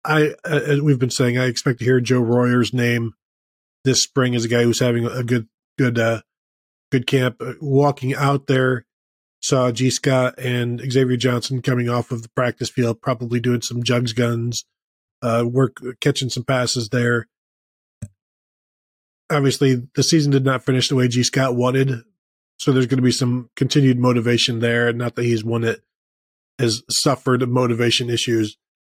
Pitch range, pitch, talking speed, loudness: 120-130 Hz, 125 Hz, 165 wpm, -19 LUFS